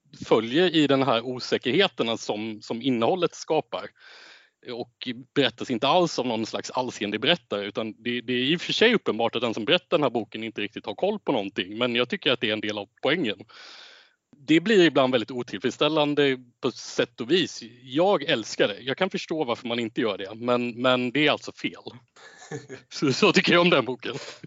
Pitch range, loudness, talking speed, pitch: 120-150 Hz, -24 LUFS, 200 wpm, 130 Hz